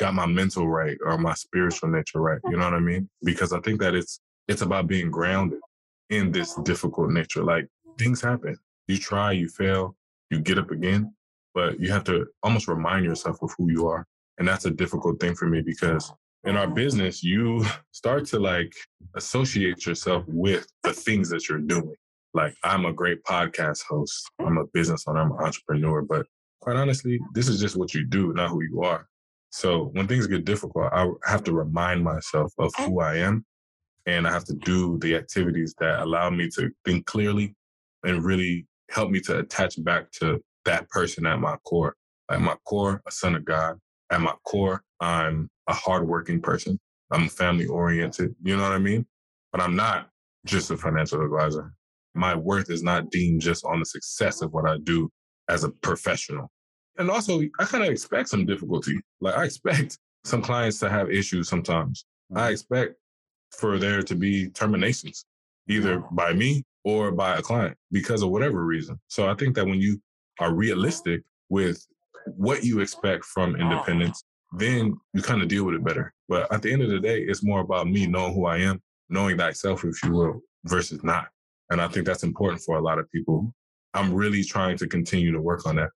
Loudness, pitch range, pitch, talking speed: -25 LUFS, 85-100 Hz, 90 Hz, 195 wpm